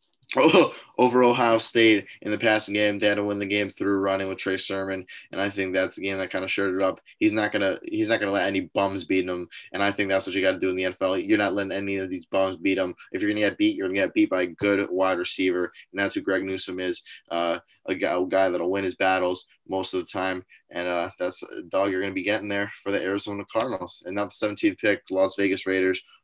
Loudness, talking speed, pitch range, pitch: -25 LUFS, 260 wpm, 95-100 Hz, 95 Hz